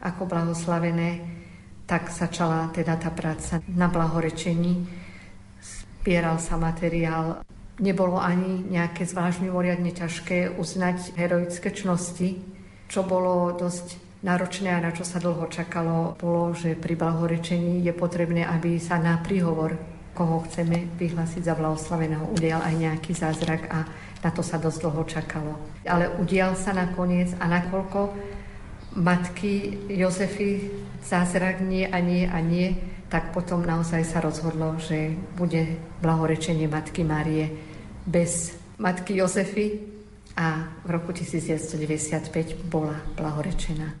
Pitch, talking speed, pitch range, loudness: 170 Hz, 125 wpm, 160-180 Hz, -26 LUFS